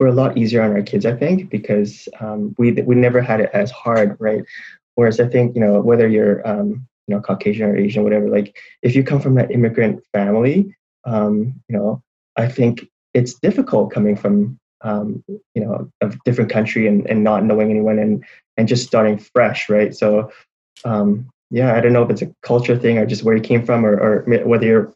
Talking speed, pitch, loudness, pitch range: 215 wpm, 110 Hz, -17 LUFS, 105-120 Hz